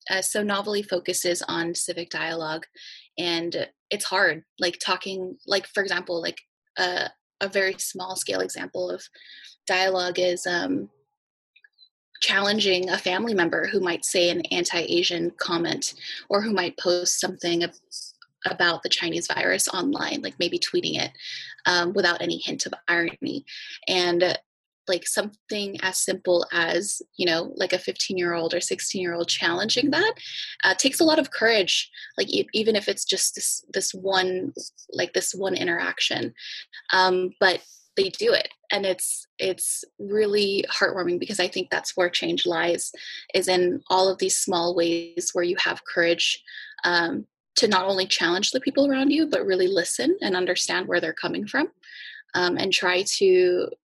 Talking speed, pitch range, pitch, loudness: 155 wpm, 175-225 Hz, 190 Hz, -24 LUFS